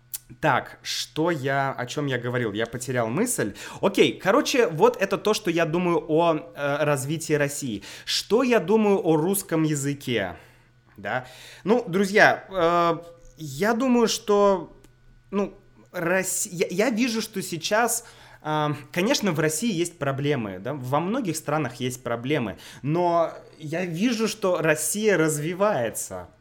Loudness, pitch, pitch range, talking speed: -24 LUFS, 160 Hz, 140-200 Hz, 135 wpm